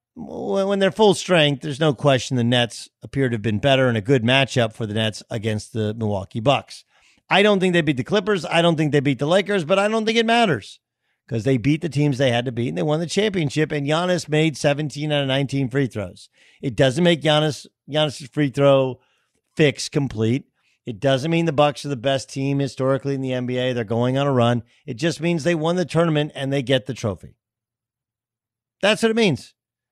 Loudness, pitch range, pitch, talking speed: -20 LUFS, 125-160 Hz, 140 Hz, 225 wpm